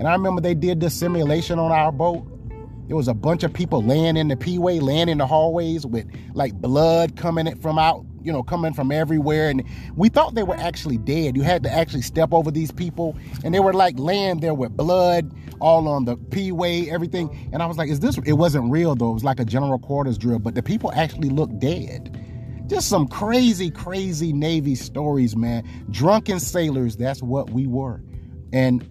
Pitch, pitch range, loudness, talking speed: 155 Hz, 130-170 Hz, -21 LUFS, 210 wpm